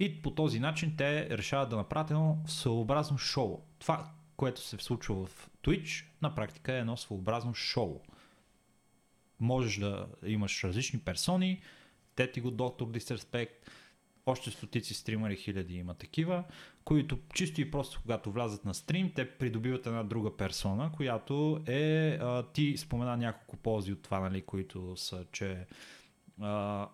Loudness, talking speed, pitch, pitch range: -35 LUFS, 145 wpm, 120 Hz, 105-150 Hz